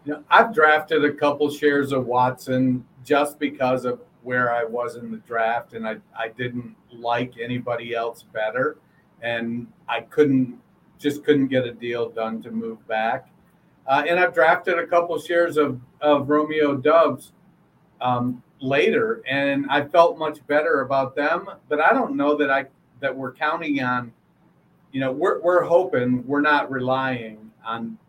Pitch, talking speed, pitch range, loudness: 135 Hz, 165 wpm, 125-150 Hz, -22 LUFS